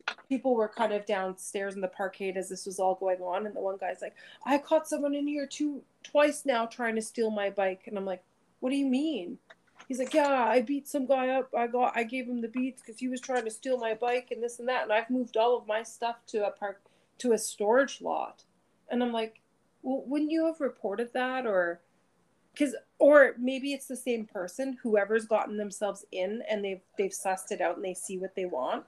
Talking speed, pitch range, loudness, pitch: 235 wpm, 200-260 Hz, -30 LUFS, 235 Hz